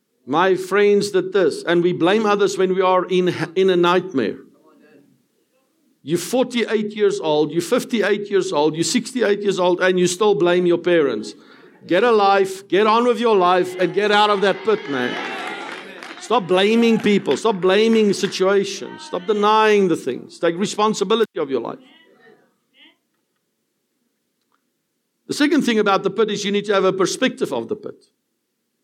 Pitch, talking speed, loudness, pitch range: 200 Hz, 165 wpm, -18 LUFS, 185-220 Hz